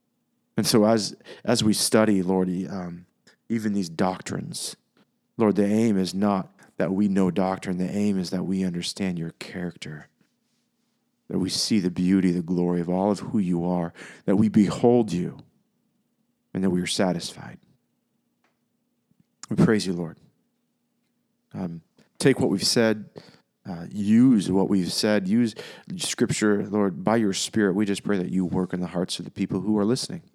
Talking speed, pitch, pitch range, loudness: 170 wpm, 95 Hz, 90-105 Hz, -24 LUFS